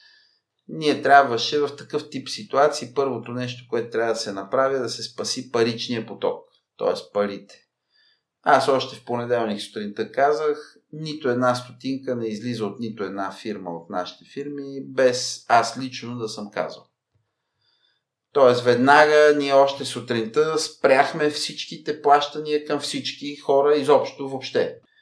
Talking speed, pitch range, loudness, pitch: 135 wpm, 120-150 Hz, -22 LUFS, 135 Hz